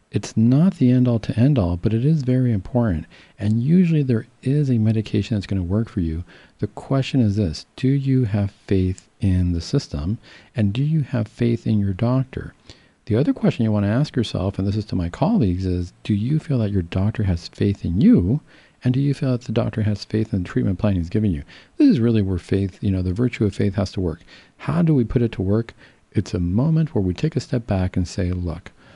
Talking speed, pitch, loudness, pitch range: 245 wpm, 110 Hz, -21 LUFS, 95-125 Hz